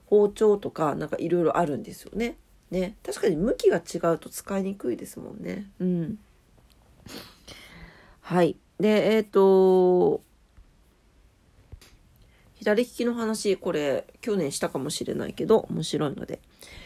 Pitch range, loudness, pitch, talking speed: 185-230 Hz, -25 LUFS, 210 Hz, 250 characters per minute